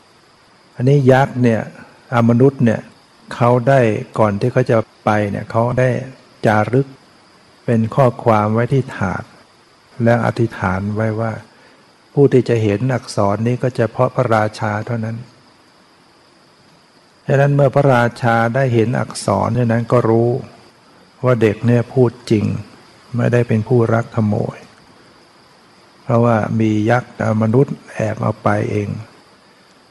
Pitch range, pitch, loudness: 110-125 Hz, 115 Hz, -16 LUFS